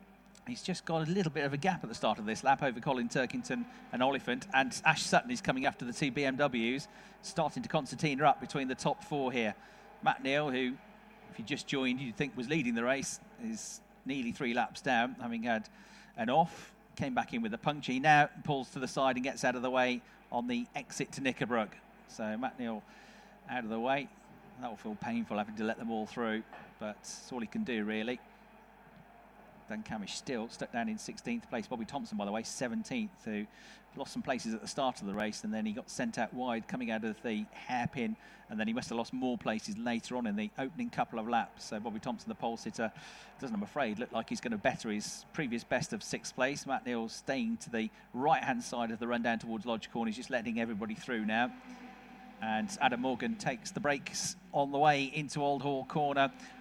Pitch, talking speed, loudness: 150 Hz, 225 wpm, -35 LUFS